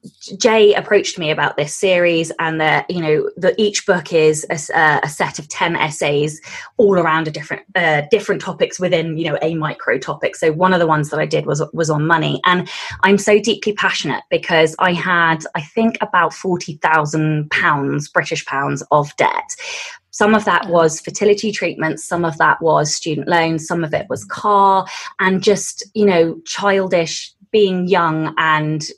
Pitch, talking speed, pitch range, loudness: 175 Hz, 180 wpm, 155-200 Hz, -16 LUFS